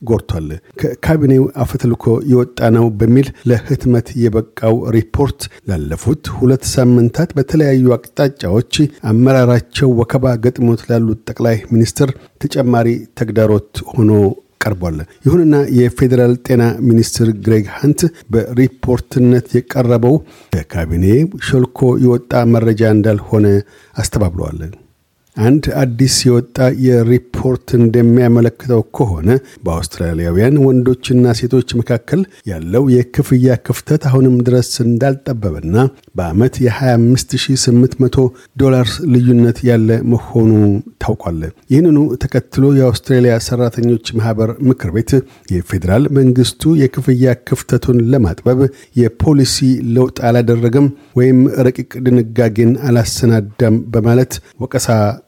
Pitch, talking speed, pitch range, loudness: 120 Hz, 90 wpm, 115-130 Hz, -13 LUFS